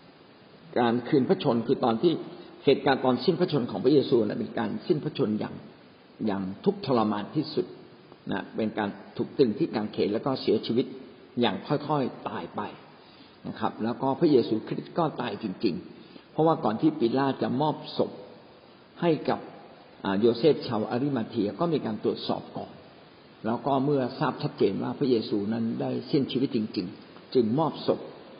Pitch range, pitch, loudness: 115-145 Hz, 130 Hz, -27 LUFS